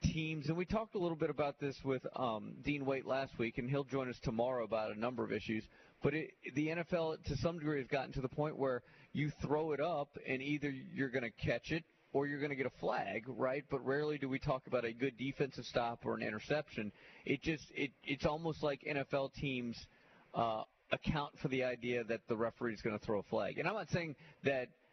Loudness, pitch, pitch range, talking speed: -39 LUFS, 140 Hz, 125-150 Hz, 235 wpm